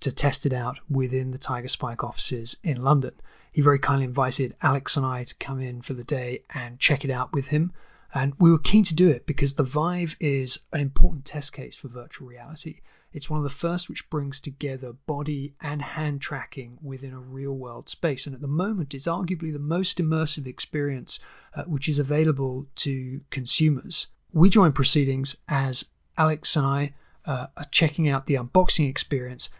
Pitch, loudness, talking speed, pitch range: 140 Hz, -25 LUFS, 190 wpm, 130-155 Hz